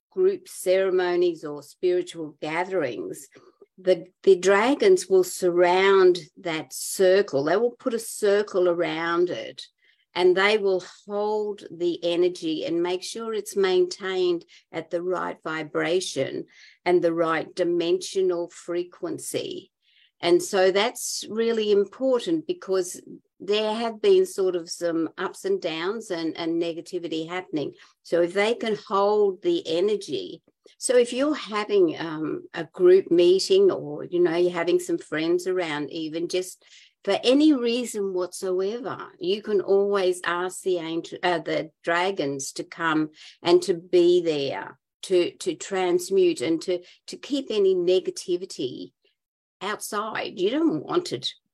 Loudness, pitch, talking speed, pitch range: -24 LUFS, 190 Hz, 135 wpm, 175-290 Hz